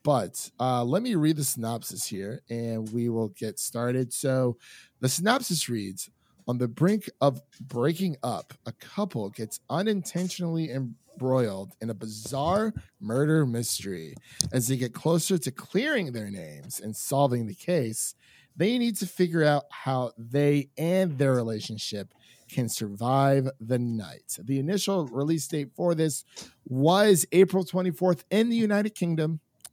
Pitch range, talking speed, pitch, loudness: 120-175 Hz, 145 wpm, 140 Hz, -27 LUFS